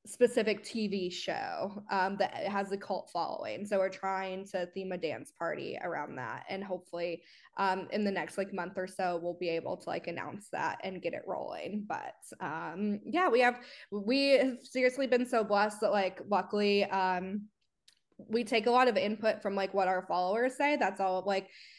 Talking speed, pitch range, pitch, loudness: 195 wpm, 190-225 Hz, 200 Hz, -33 LUFS